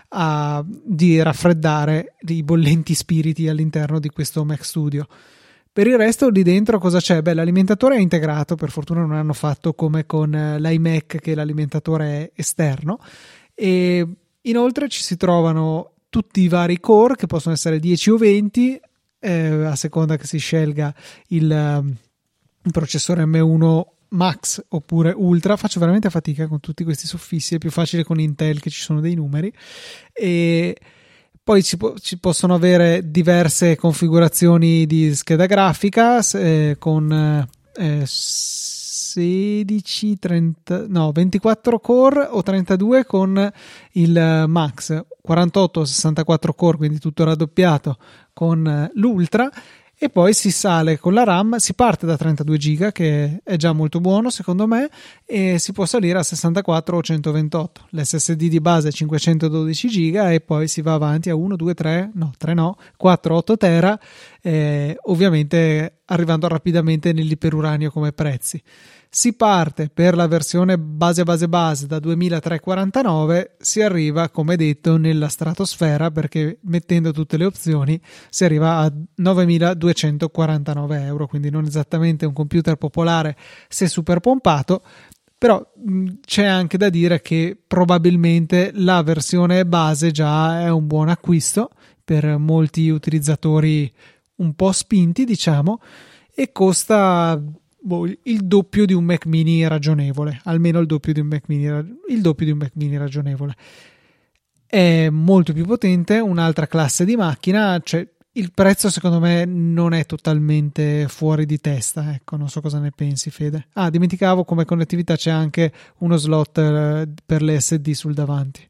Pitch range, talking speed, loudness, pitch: 155-185 Hz, 145 wpm, -18 LUFS, 165 Hz